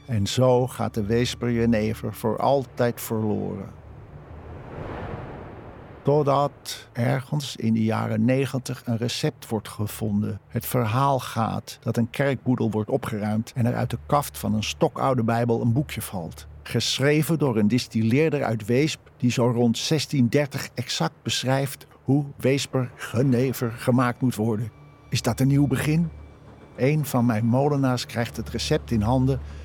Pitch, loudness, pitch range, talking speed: 125 Hz, -24 LUFS, 115-135 Hz, 145 wpm